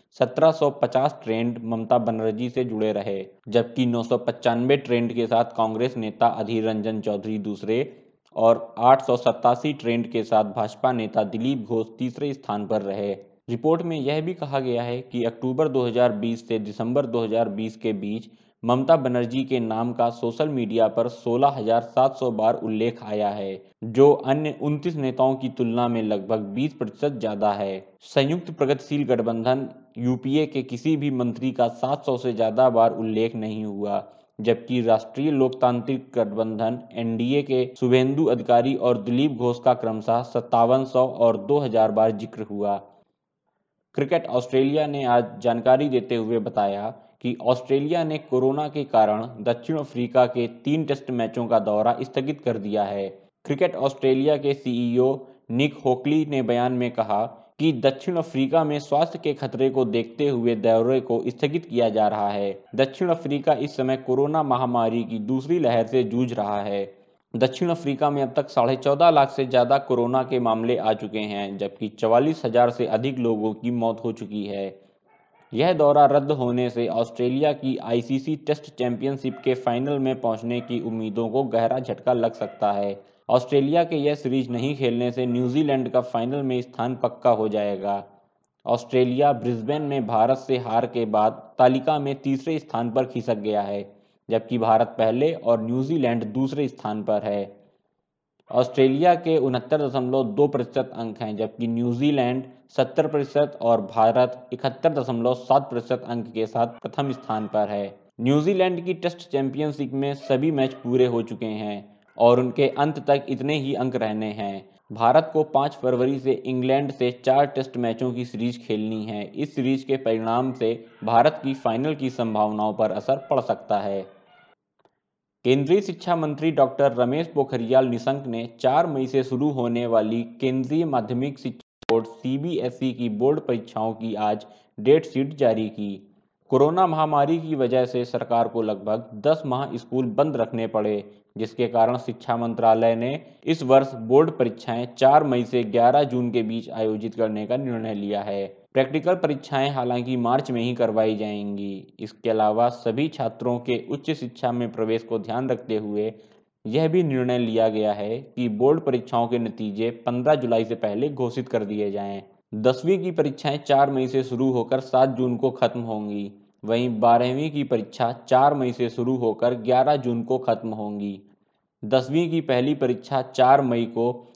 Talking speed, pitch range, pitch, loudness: 165 wpm, 115-135 Hz, 125 Hz, -23 LUFS